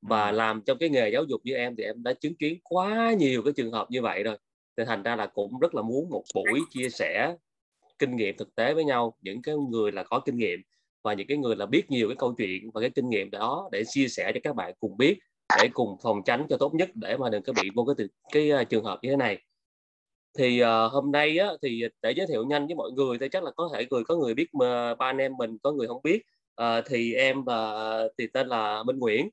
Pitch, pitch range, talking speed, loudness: 130 Hz, 115-150 Hz, 270 wpm, -27 LUFS